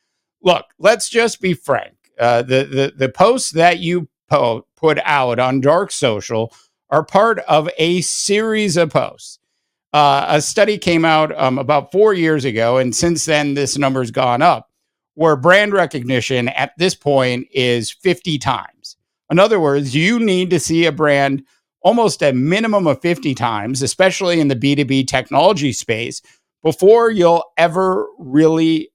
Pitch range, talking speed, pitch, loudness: 135-180 Hz, 165 wpm, 155 Hz, -15 LUFS